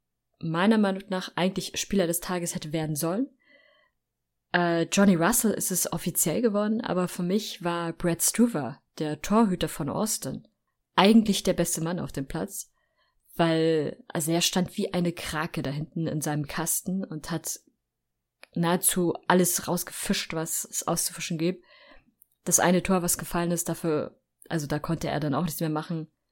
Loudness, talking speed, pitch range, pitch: -26 LUFS, 160 wpm, 160-190 Hz, 175 Hz